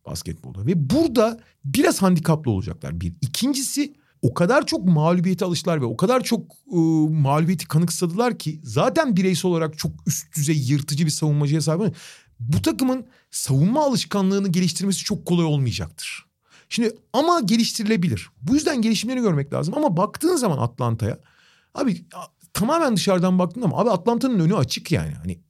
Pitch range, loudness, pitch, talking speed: 150-225 Hz, -21 LUFS, 175 Hz, 145 wpm